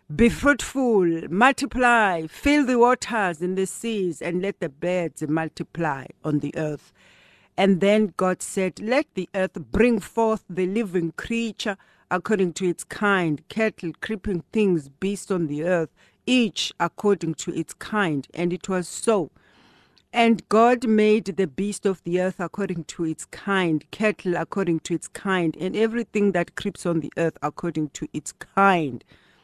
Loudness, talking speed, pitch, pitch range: -23 LUFS, 155 wpm, 185 Hz, 165-215 Hz